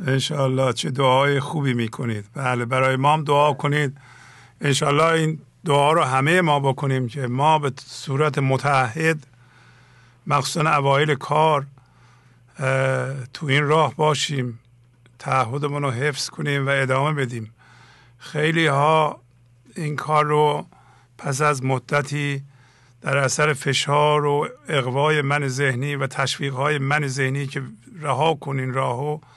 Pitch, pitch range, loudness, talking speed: 140 Hz, 130-150 Hz, -21 LUFS, 125 wpm